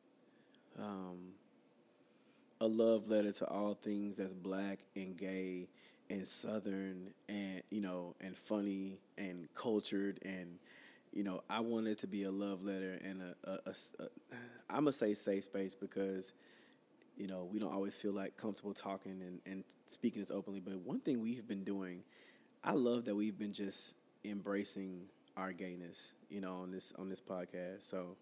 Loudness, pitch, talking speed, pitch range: -42 LUFS, 95 Hz, 170 wpm, 95-100 Hz